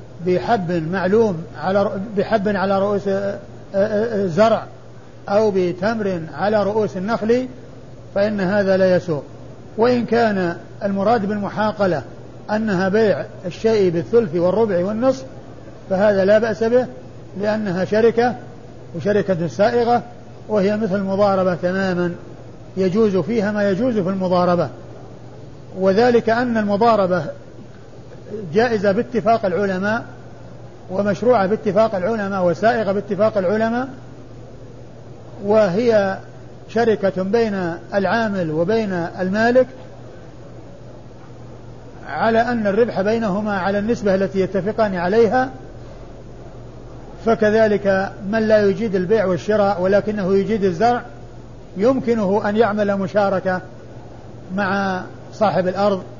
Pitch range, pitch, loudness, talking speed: 180-220 Hz, 200 Hz, -19 LUFS, 95 wpm